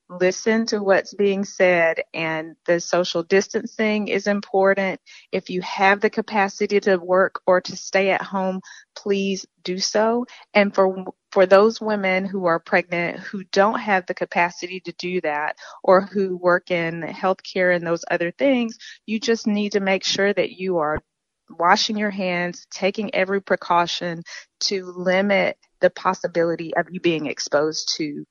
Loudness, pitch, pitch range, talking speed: -21 LUFS, 190 Hz, 175-200 Hz, 160 wpm